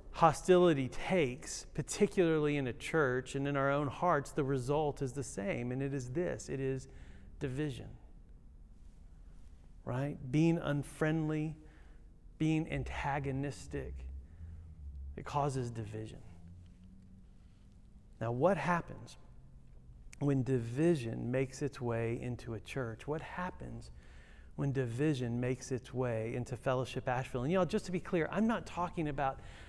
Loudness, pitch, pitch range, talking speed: -35 LUFS, 130 Hz, 95-150 Hz, 125 wpm